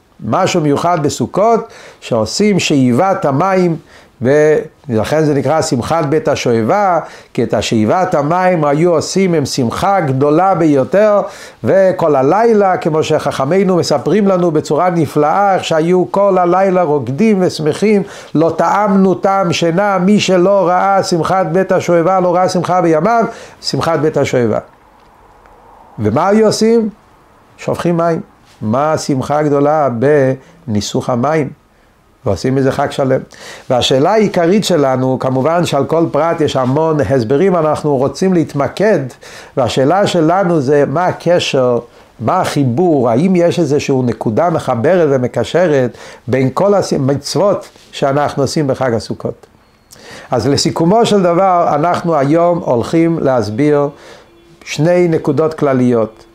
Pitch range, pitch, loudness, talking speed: 135-180 Hz, 155 Hz, -13 LUFS, 120 wpm